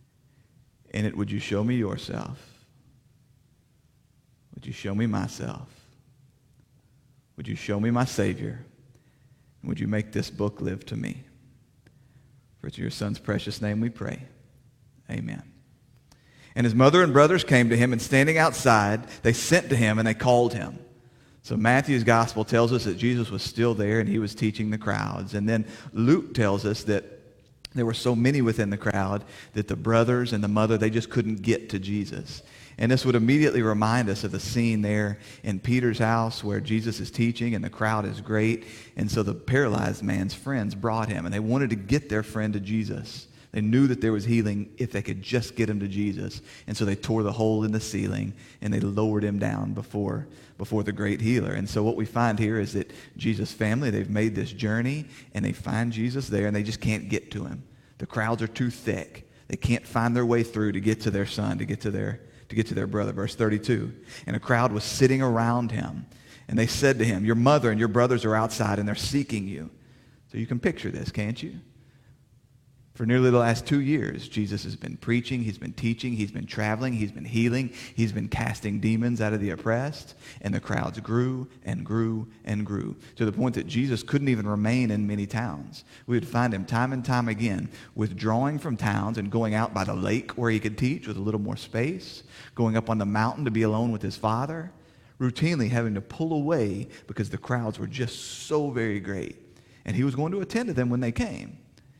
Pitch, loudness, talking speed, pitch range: 115 Hz, -26 LUFS, 210 wpm, 105-125 Hz